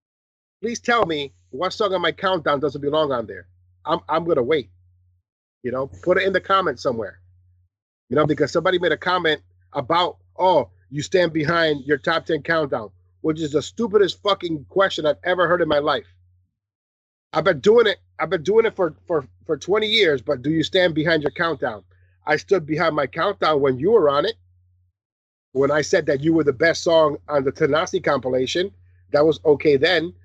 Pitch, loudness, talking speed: 150 Hz, -20 LUFS, 195 wpm